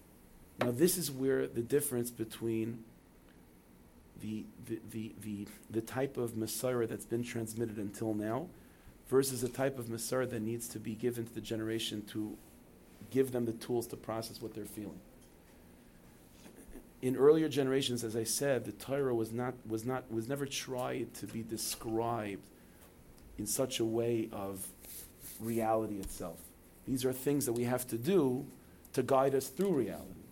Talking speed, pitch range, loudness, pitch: 160 wpm, 105-125 Hz, -35 LUFS, 115 Hz